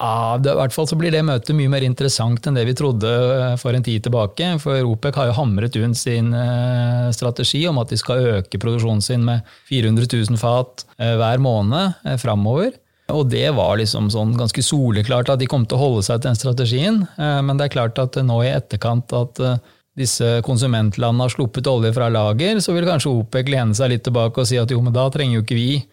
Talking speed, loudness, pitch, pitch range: 210 wpm, -18 LUFS, 125 Hz, 115-135 Hz